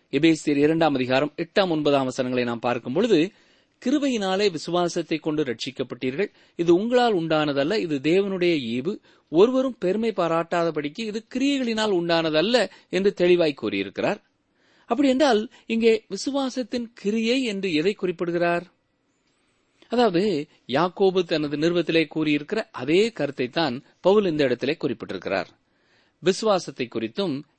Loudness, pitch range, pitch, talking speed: -23 LUFS, 150-215 Hz, 175 Hz, 105 wpm